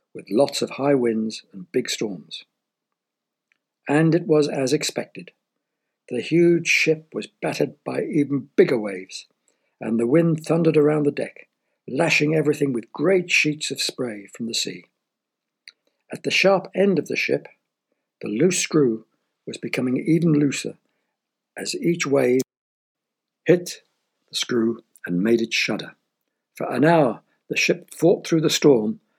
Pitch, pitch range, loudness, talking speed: 150 Hz, 125-160 Hz, -21 LUFS, 150 wpm